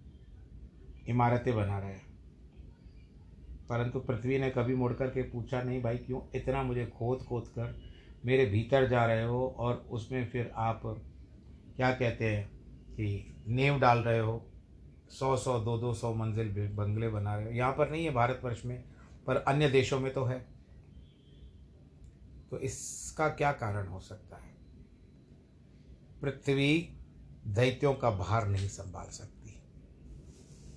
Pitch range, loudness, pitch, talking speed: 90-125 Hz, -32 LUFS, 115 Hz, 140 wpm